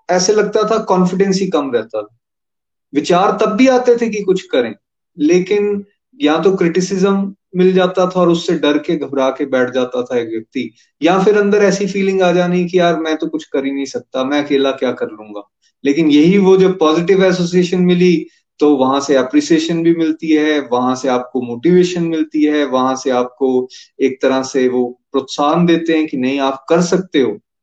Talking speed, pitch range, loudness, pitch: 200 wpm, 135-185 Hz, -14 LUFS, 165 Hz